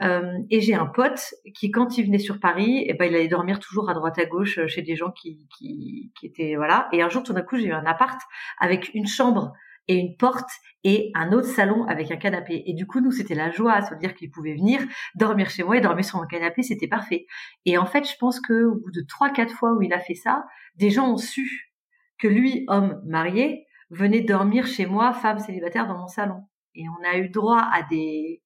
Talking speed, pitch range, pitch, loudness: 240 wpm, 175-245 Hz, 205 Hz, -23 LUFS